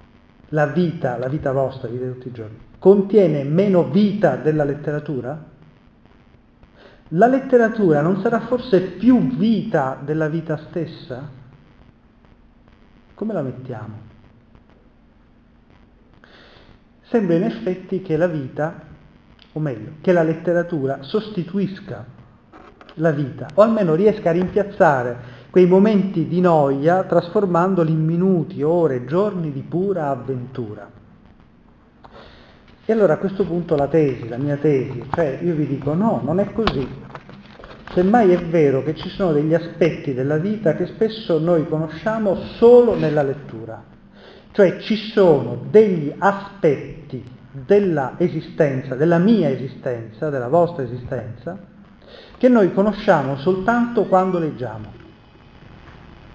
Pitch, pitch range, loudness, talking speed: 165 Hz, 135-195 Hz, -19 LUFS, 120 wpm